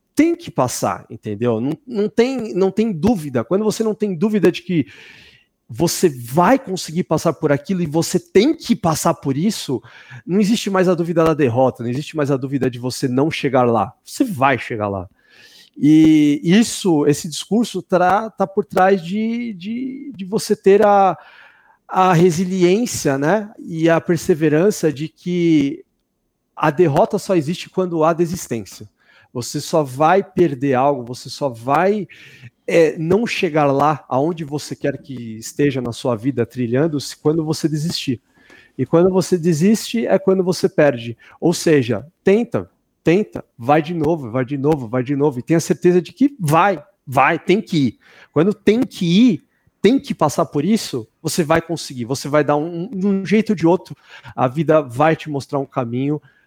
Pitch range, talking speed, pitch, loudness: 140-190 Hz, 170 wpm, 165 Hz, -18 LUFS